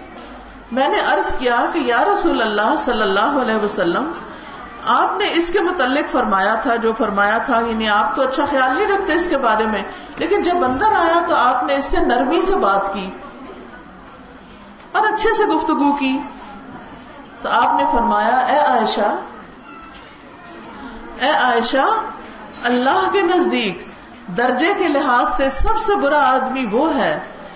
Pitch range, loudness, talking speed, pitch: 235-350 Hz, -17 LUFS, 155 wpm, 270 Hz